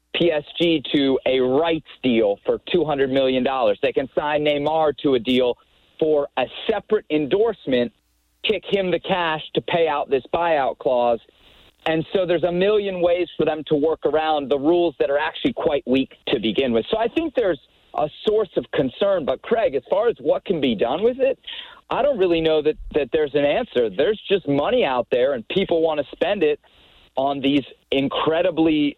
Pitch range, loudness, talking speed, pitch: 145-205 Hz, -21 LUFS, 190 wpm, 160 Hz